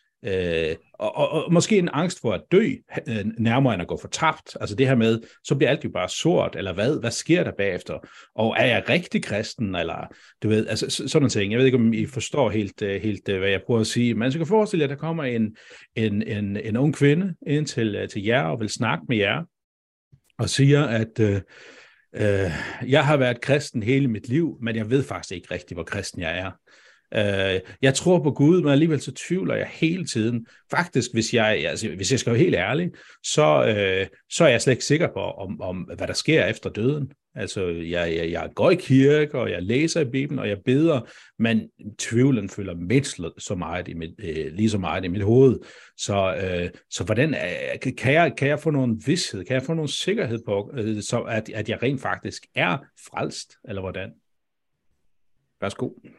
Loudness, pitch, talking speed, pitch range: -23 LUFS, 115 Hz, 215 wpm, 100-145 Hz